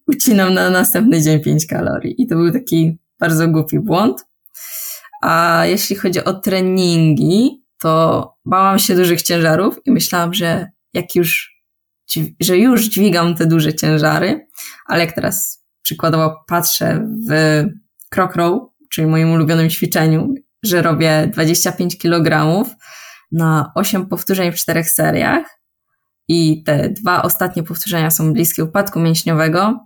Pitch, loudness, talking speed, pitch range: 170 Hz, -15 LUFS, 130 wpm, 160-195 Hz